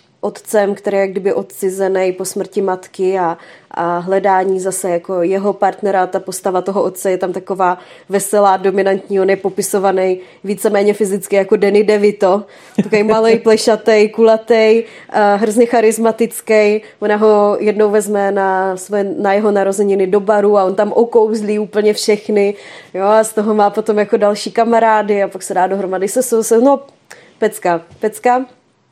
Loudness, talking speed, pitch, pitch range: -14 LUFS, 160 wpm, 205 Hz, 195-215 Hz